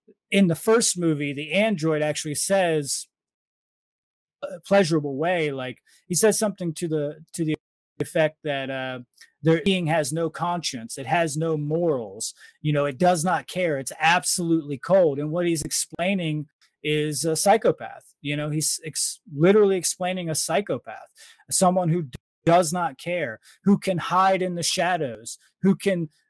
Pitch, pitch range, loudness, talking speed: 165 Hz, 150-185 Hz, -23 LUFS, 155 wpm